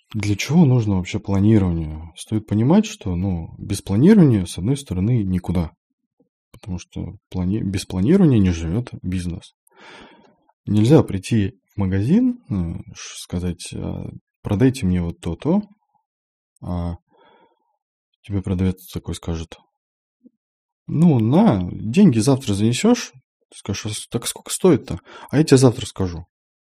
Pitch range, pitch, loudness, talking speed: 90-150 Hz, 105 Hz, -19 LUFS, 120 wpm